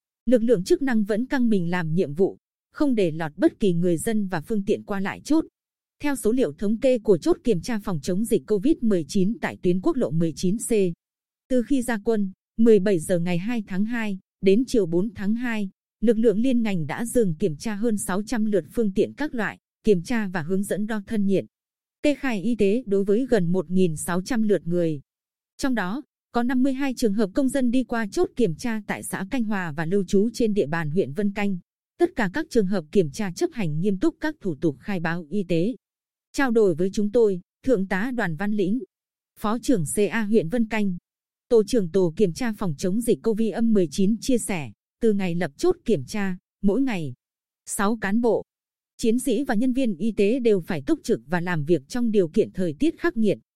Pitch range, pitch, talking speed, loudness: 185-235 Hz, 210 Hz, 215 wpm, -24 LUFS